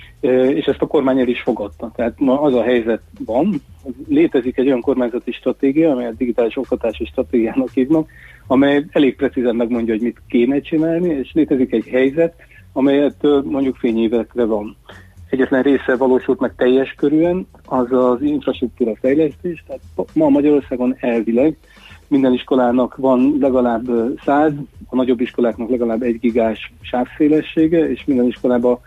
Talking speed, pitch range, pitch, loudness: 140 wpm, 120-140 Hz, 130 Hz, -17 LUFS